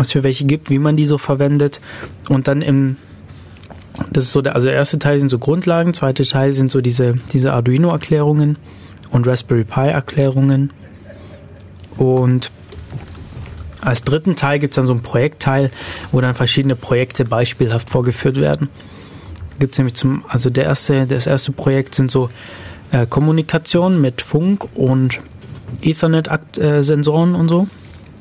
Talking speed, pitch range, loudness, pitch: 150 wpm, 115-145 Hz, -15 LUFS, 135 Hz